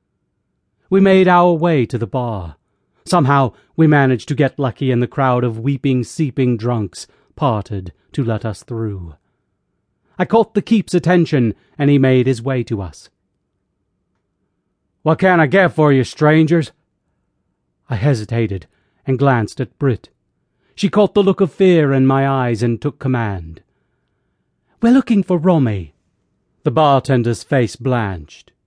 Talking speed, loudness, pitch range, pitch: 145 wpm, -16 LUFS, 110-160 Hz, 130 Hz